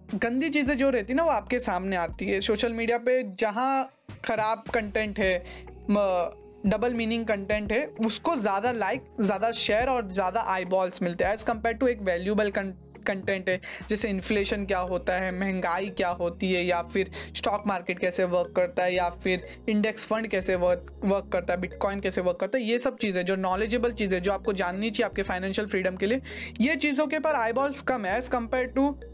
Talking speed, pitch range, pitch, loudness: 200 wpm, 185-235 Hz, 210 Hz, -27 LUFS